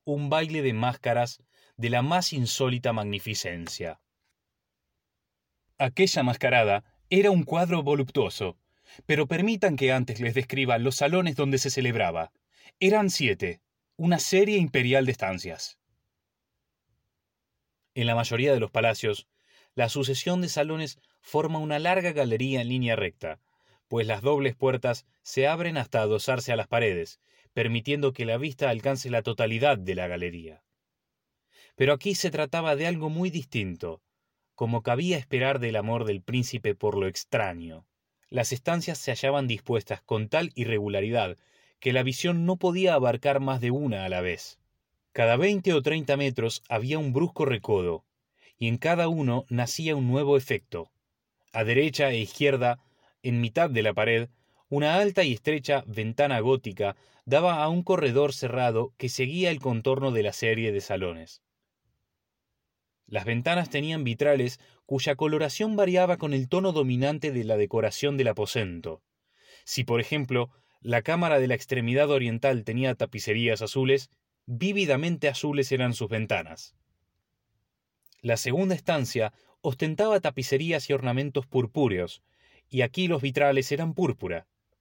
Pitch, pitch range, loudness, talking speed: 135 Hz, 115-150 Hz, -26 LUFS, 145 wpm